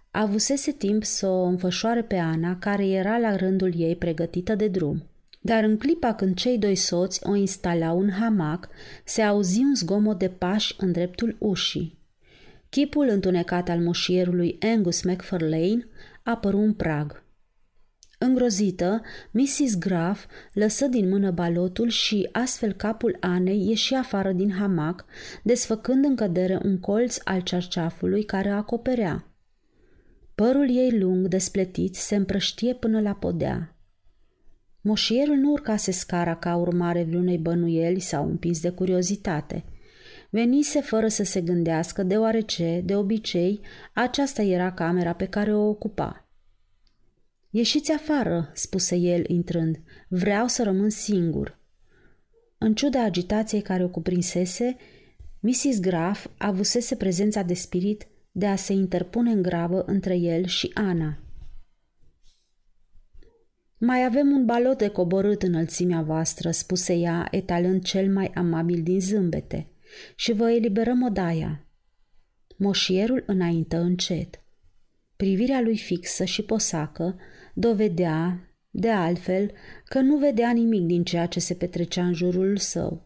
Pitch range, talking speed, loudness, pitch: 175-220 Hz, 130 wpm, -24 LUFS, 195 Hz